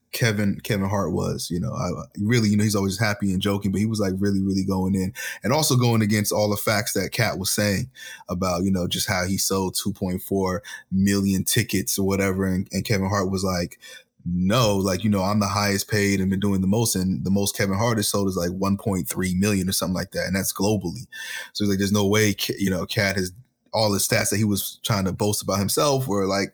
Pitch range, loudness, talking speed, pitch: 95-105 Hz, -23 LUFS, 240 wpm, 100 Hz